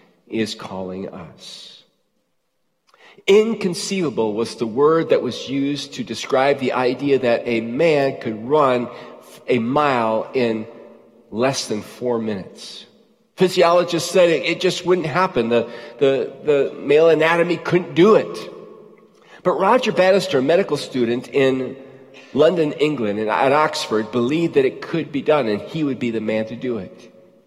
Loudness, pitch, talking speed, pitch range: -19 LUFS, 135 Hz, 145 wpm, 115-170 Hz